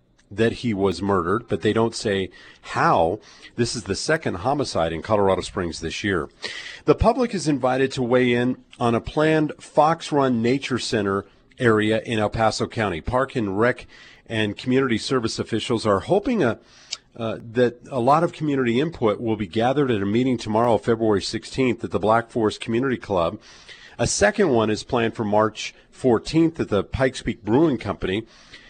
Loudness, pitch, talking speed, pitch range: -22 LUFS, 115 Hz, 175 wpm, 105-125 Hz